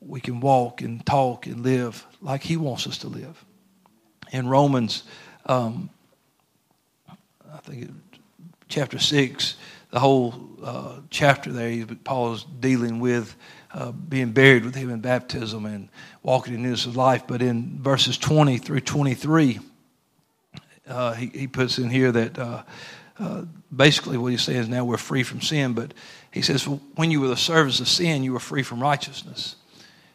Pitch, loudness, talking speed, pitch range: 130 Hz, -23 LUFS, 165 wpm, 120-140 Hz